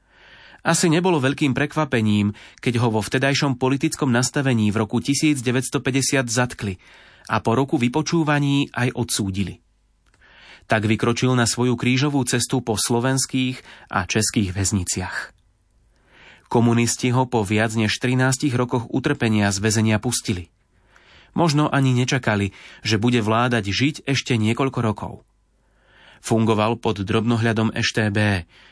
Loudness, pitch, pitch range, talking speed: -21 LUFS, 120 Hz, 110-135 Hz, 115 wpm